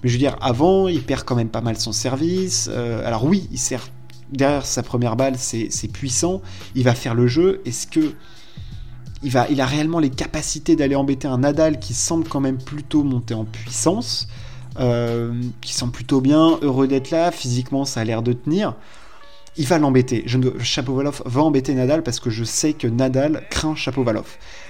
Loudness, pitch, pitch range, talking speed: -20 LUFS, 130 Hz, 120-150 Hz, 195 wpm